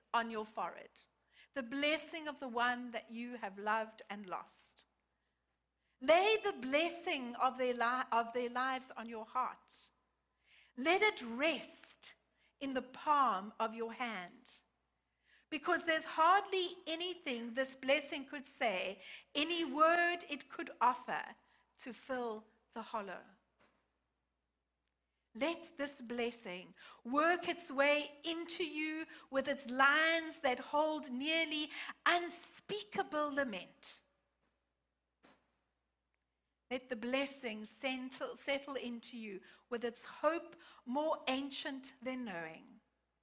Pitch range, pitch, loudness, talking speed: 225-310 Hz, 260 Hz, -37 LUFS, 110 wpm